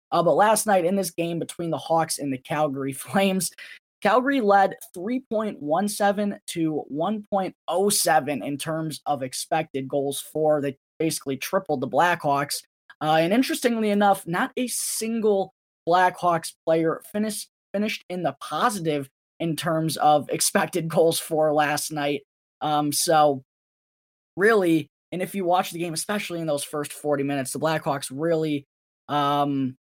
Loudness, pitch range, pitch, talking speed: -24 LUFS, 145-195 Hz, 165 Hz, 145 wpm